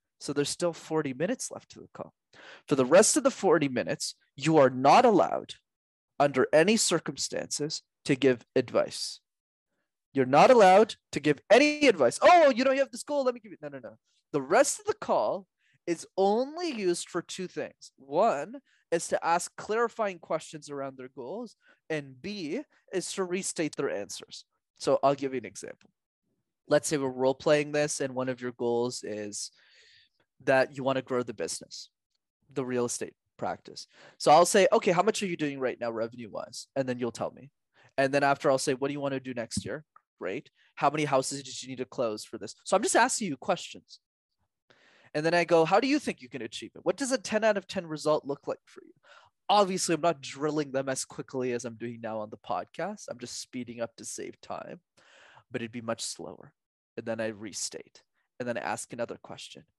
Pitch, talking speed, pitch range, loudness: 150 Hz, 215 wpm, 130-190 Hz, -28 LUFS